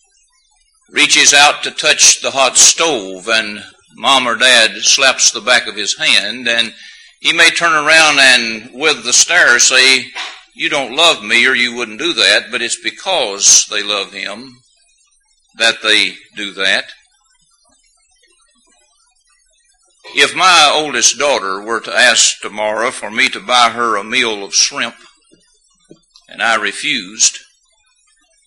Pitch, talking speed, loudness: 195 Hz, 140 wpm, -10 LUFS